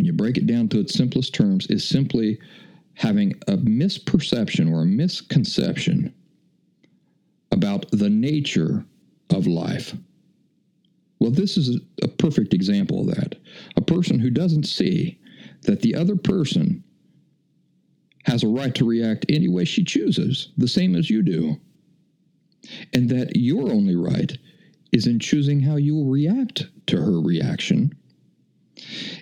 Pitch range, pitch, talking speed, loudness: 145-195 Hz, 175 Hz, 140 wpm, -21 LUFS